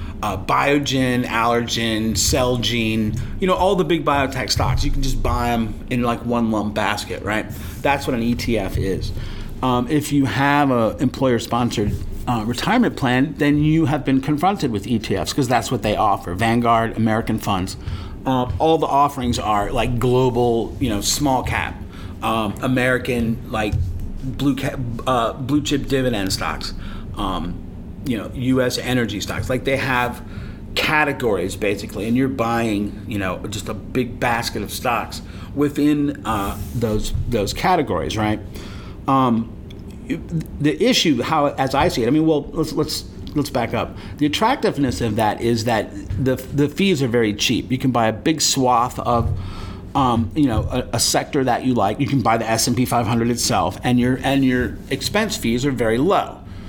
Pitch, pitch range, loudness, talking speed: 120 Hz, 105-130 Hz, -20 LUFS, 170 wpm